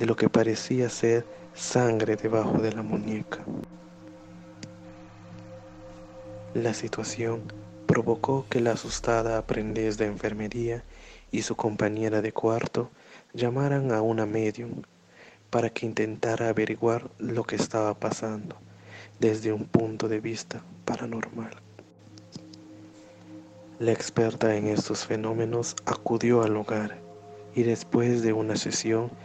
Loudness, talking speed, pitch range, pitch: -28 LUFS, 115 wpm, 105-115 Hz, 110 Hz